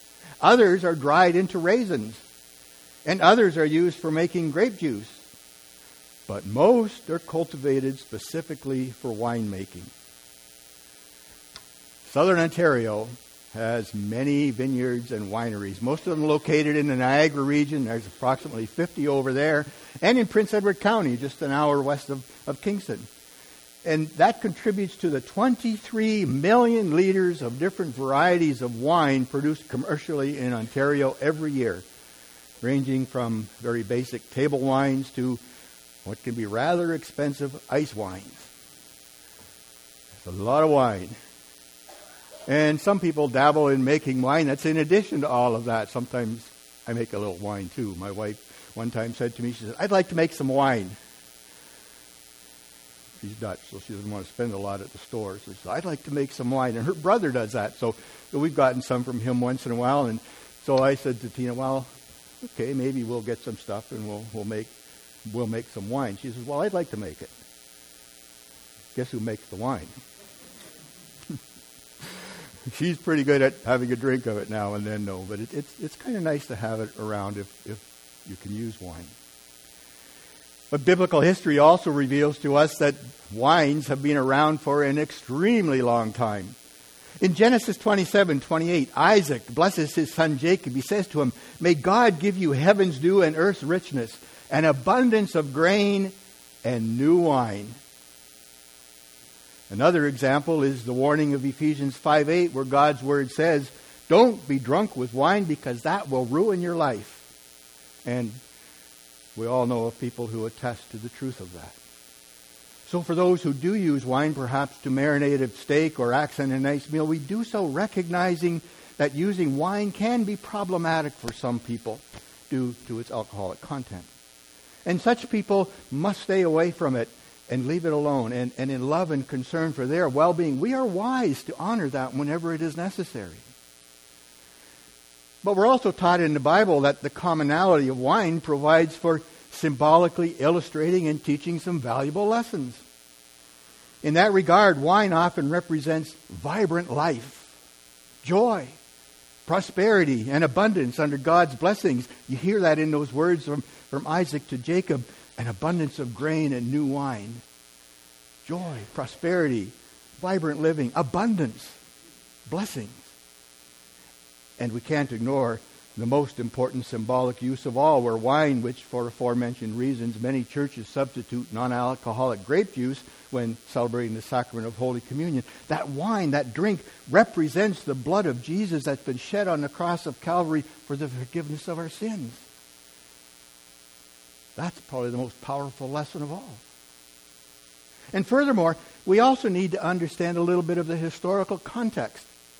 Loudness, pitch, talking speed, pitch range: -25 LUFS, 135 Hz, 160 wpm, 105-160 Hz